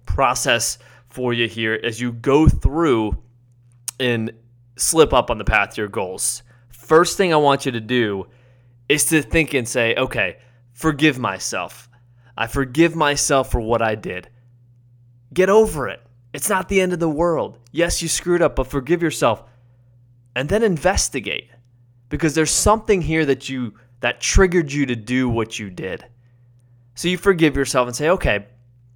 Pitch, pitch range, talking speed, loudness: 125 Hz, 120-155 Hz, 165 wpm, -19 LUFS